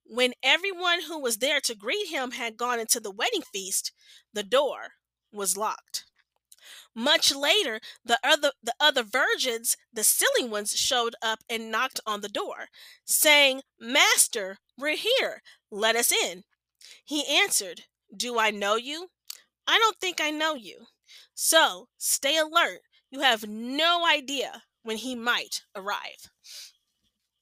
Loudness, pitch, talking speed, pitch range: -24 LUFS, 265 Hz, 140 wpm, 230-315 Hz